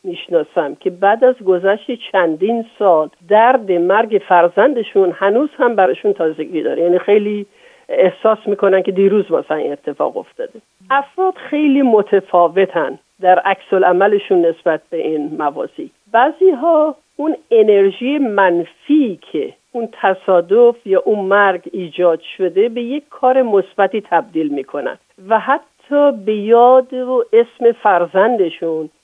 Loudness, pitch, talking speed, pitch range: -14 LUFS, 205 Hz, 125 wpm, 185-255 Hz